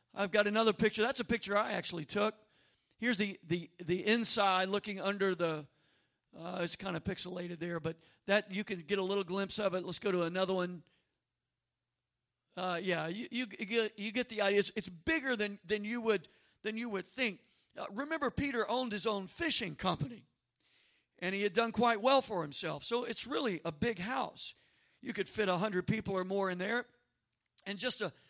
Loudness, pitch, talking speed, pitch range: -34 LUFS, 200 Hz, 200 wpm, 180-220 Hz